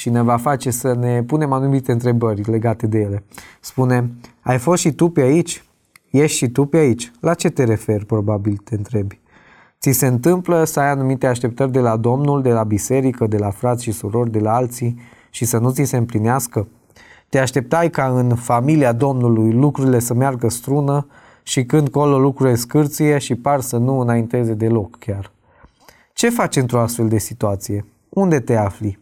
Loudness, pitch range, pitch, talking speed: -17 LUFS, 115-140 Hz, 125 Hz, 185 wpm